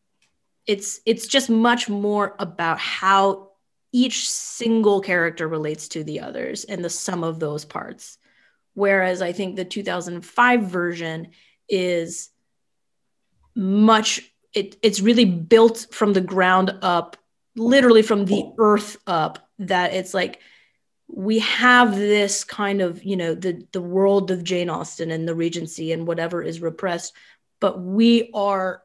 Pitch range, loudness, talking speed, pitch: 175-215 Hz, -20 LUFS, 140 wpm, 195 Hz